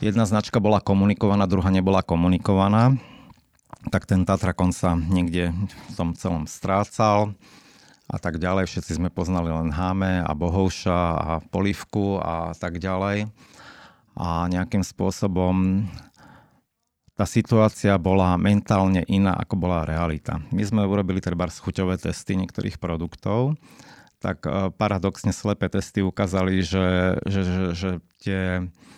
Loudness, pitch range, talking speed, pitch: -23 LUFS, 90-100 Hz, 125 wpm, 95 Hz